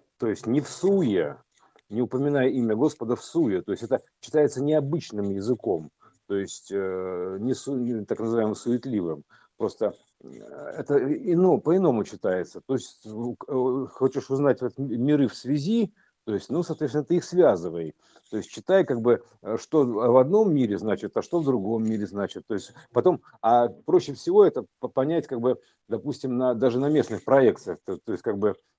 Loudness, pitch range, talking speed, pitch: -25 LUFS, 120-170 Hz, 165 wpm, 130 Hz